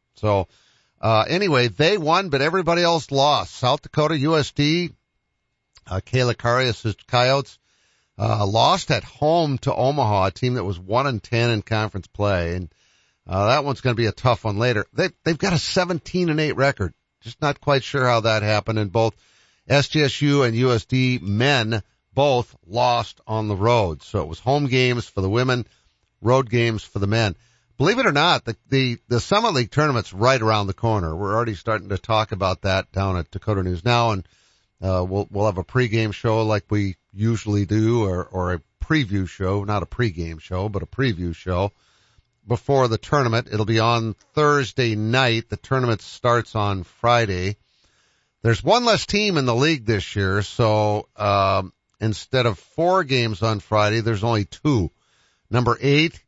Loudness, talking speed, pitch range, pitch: -21 LUFS, 180 wpm, 100-130 Hz, 115 Hz